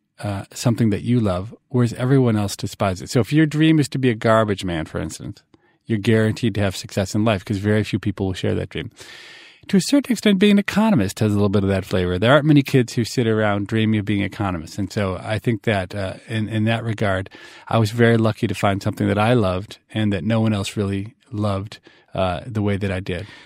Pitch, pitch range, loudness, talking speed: 110 Hz, 100-120 Hz, -20 LUFS, 245 wpm